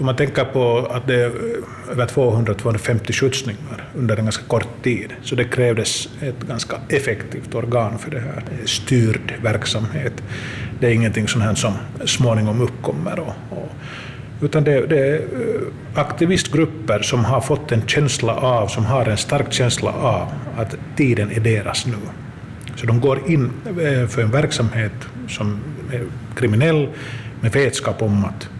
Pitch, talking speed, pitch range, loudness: 120 Hz, 145 wpm, 115-135 Hz, -20 LUFS